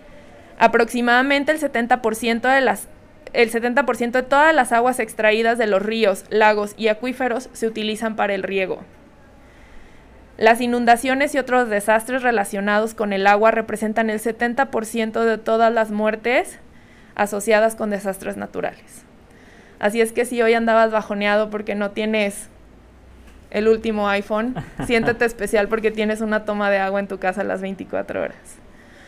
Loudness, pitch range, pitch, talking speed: -19 LUFS, 210-240 Hz, 225 Hz, 145 wpm